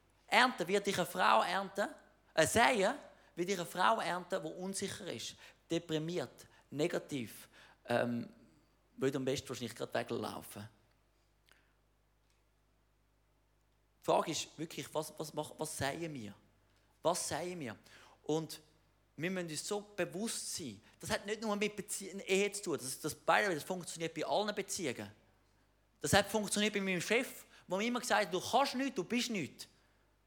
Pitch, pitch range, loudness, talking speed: 170 Hz, 130-200 Hz, -36 LUFS, 155 wpm